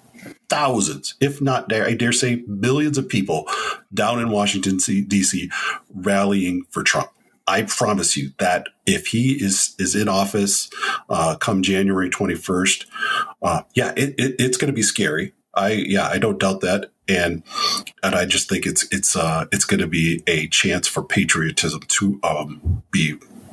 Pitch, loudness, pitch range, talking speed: 100 Hz, -20 LUFS, 95-125 Hz, 165 wpm